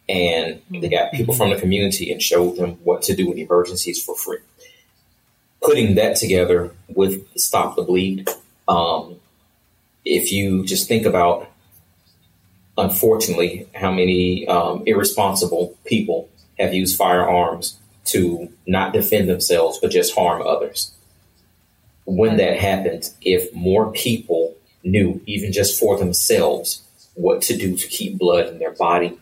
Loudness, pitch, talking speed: -19 LUFS, 95 Hz, 140 wpm